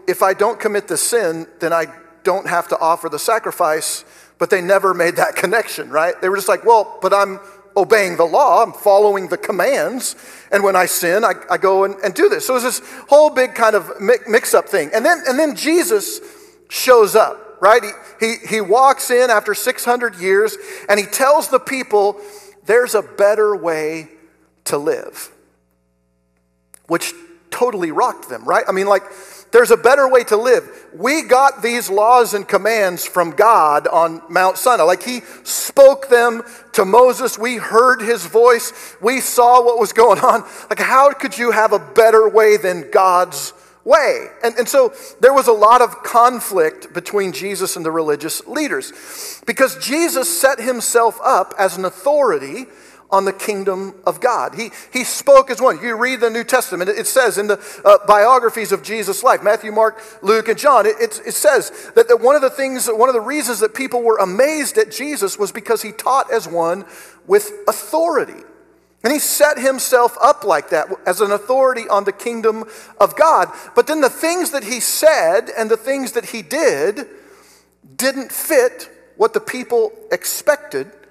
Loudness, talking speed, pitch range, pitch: -15 LUFS, 185 wpm, 200-305 Hz, 240 Hz